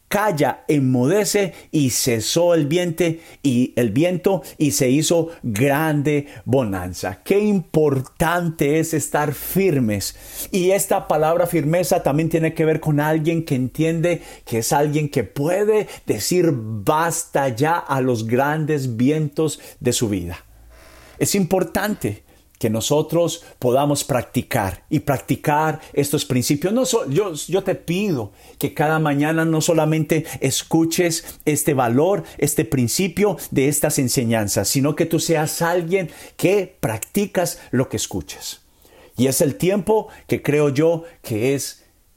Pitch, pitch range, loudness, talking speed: 150 Hz, 130-170 Hz, -20 LUFS, 135 wpm